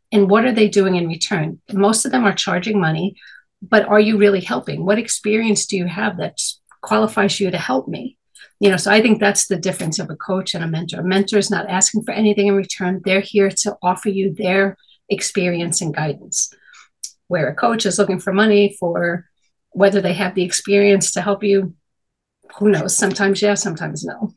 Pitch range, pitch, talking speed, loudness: 185-205 Hz, 195 Hz, 205 wpm, -17 LUFS